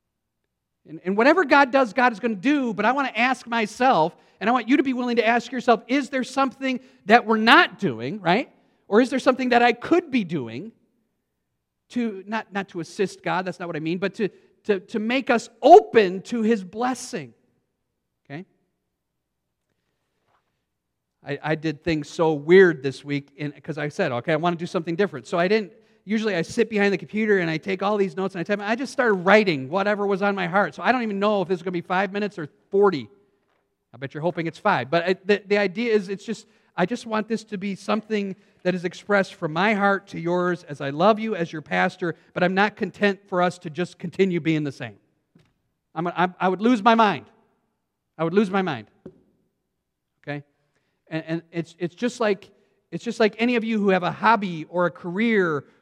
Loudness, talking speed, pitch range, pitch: -22 LUFS, 220 wpm, 170-225 Hz, 200 Hz